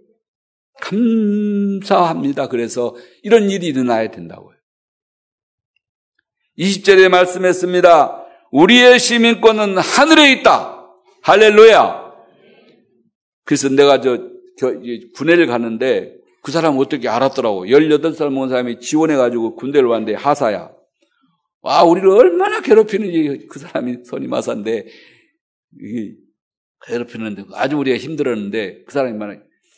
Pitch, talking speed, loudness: 170 Hz, 260 characters per minute, -14 LUFS